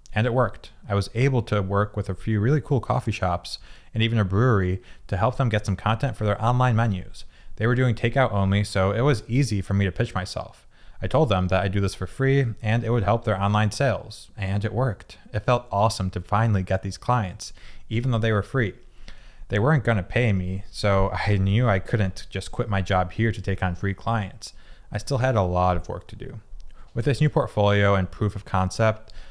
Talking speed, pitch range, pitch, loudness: 230 wpm, 95-120 Hz, 105 Hz, -24 LUFS